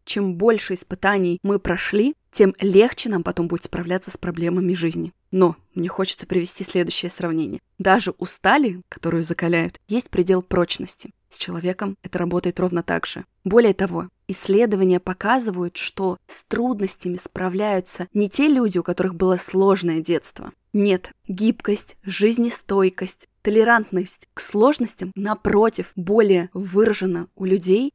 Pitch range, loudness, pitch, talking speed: 180-210 Hz, -21 LUFS, 190 Hz, 135 wpm